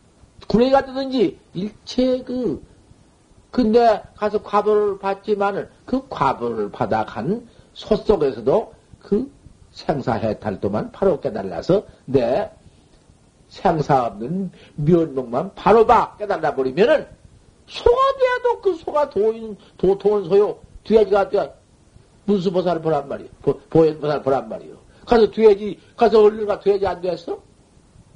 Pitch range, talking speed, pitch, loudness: 180-230 Hz, 260 characters per minute, 205 Hz, -20 LUFS